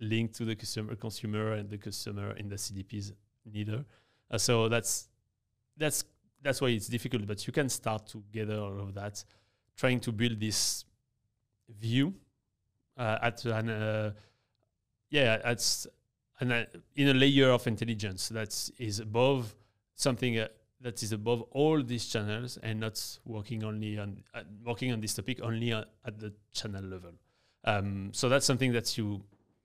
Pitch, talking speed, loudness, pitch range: 110 Hz, 160 wpm, -32 LUFS, 105-120 Hz